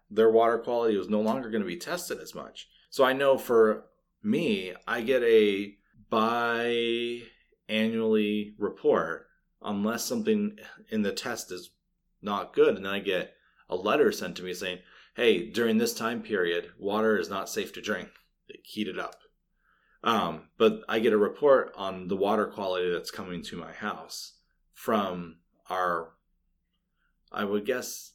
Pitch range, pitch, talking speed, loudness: 100-120 Hz, 110 Hz, 160 wpm, -28 LUFS